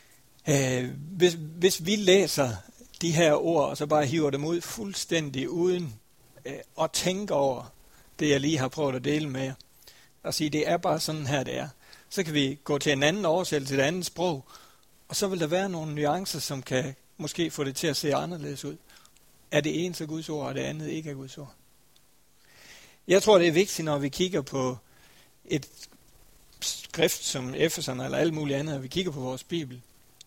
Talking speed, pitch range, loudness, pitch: 200 wpm, 140-170 Hz, -27 LUFS, 150 Hz